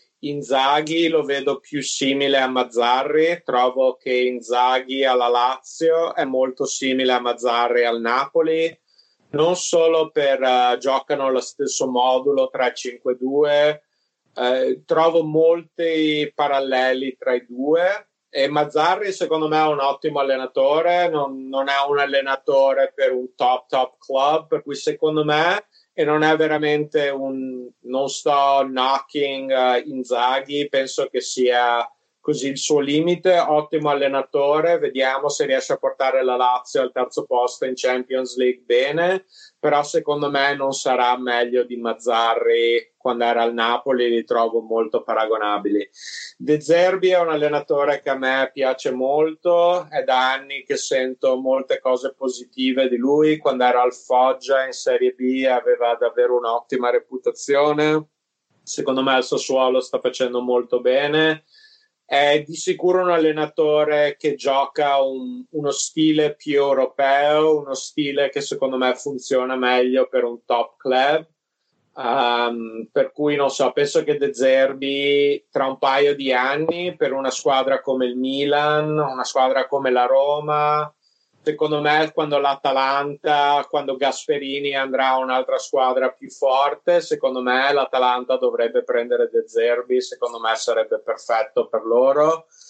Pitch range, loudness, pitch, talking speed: 130-155 Hz, -20 LUFS, 140 Hz, 140 wpm